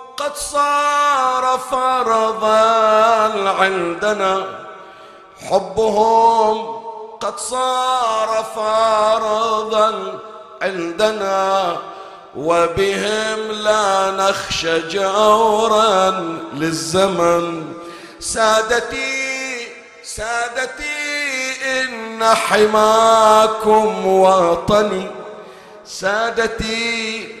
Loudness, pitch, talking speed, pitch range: -16 LUFS, 220 Hz, 45 wpm, 195-230 Hz